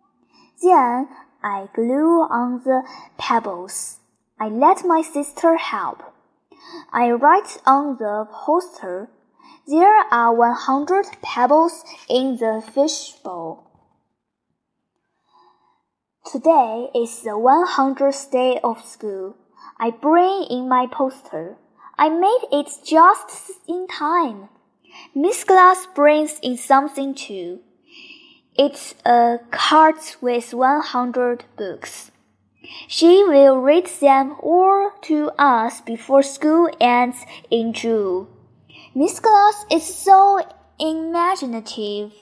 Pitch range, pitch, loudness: 240-335 Hz, 285 Hz, -17 LUFS